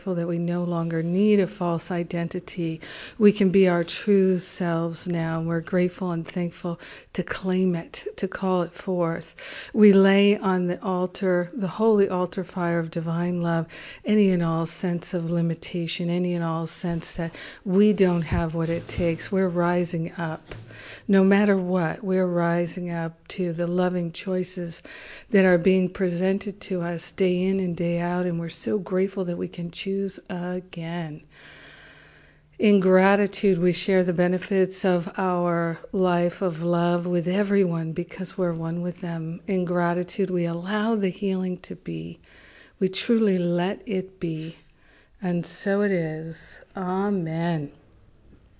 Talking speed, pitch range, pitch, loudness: 155 wpm, 170-190 Hz, 180 Hz, -24 LUFS